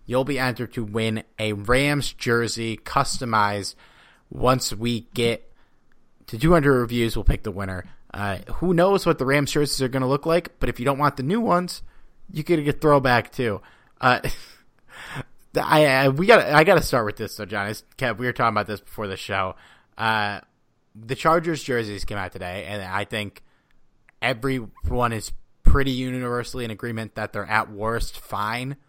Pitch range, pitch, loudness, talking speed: 110-140 Hz, 120 Hz, -23 LUFS, 175 wpm